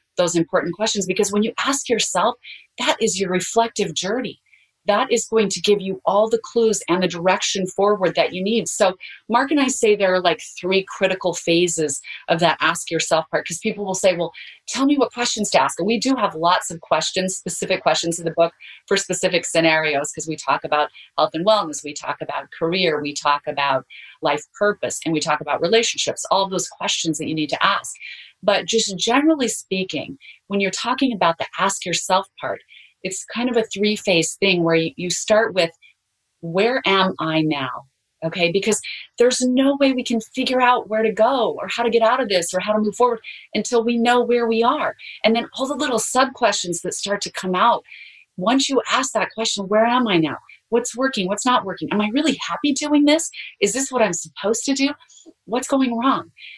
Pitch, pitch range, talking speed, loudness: 205 Hz, 175-235 Hz, 210 wpm, -20 LUFS